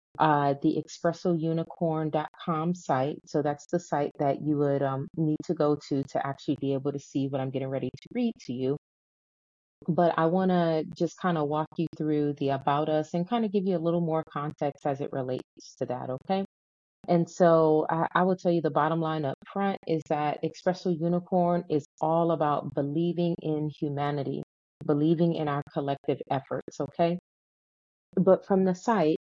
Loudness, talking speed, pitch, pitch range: -28 LUFS, 185 wpm, 155 Hz, 145-175 Hz